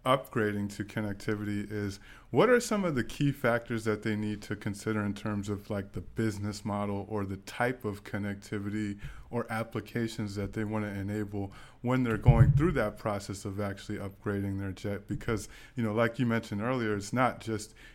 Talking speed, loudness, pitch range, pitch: 185 wpm, -32 LUFS, 100-115 Hz, 105 Hz